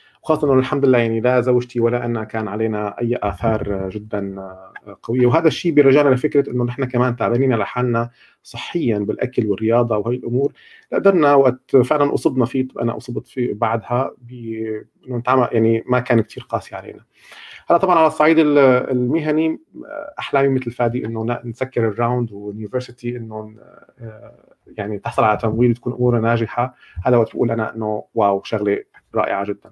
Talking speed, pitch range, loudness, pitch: 150 wpm, 110-130 Hz, -19 LUFS, 120 Hz